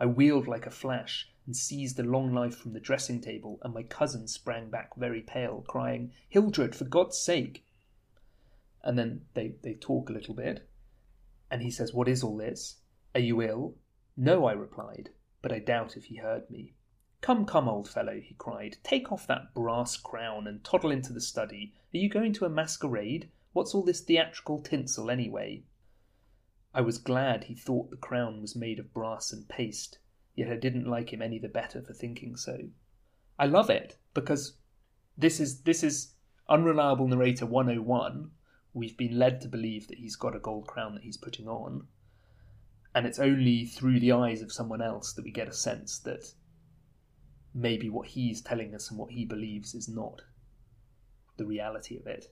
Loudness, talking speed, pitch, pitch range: -31 LUFS, 185 wpm, 120 Hz, 110-130 Hz